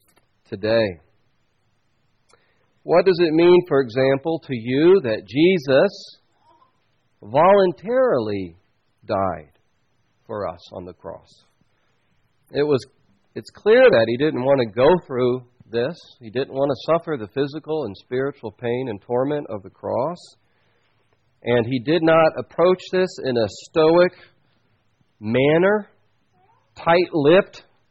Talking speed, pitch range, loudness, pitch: 120 wpm, 115-165 Hz, -19 LUFS, 135 Hz